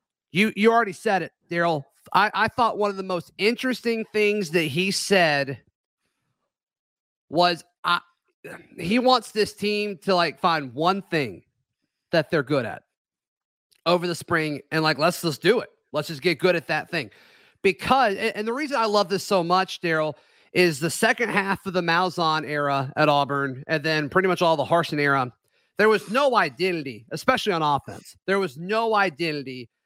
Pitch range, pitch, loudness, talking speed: 155-205 Hz, 175 Hz, -23 LUFS, 175 wpm